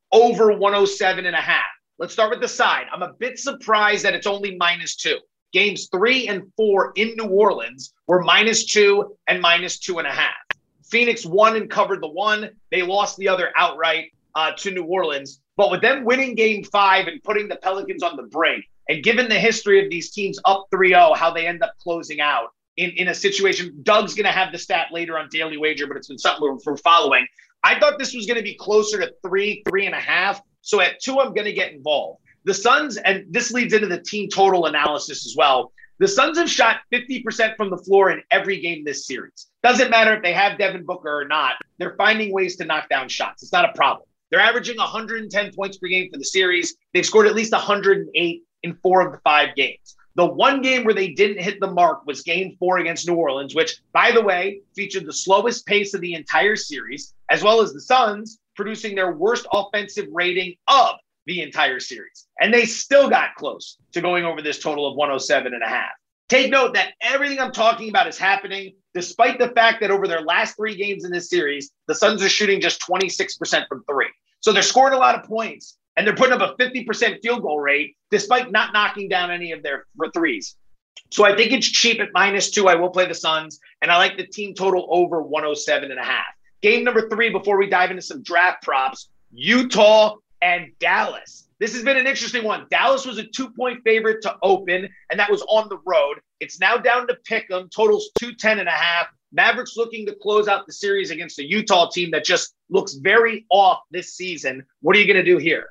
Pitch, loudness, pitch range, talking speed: 200 Hz, -19 LUFS, 180-230 Hz, 220 wpm